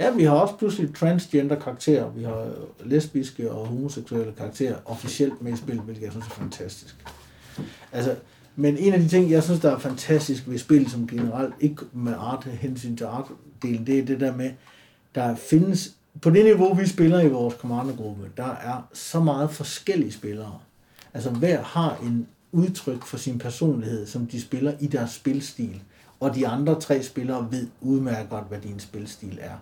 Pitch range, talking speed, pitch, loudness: 120-145 Hz, 185 wpm, 130 Hz, -24 LUFS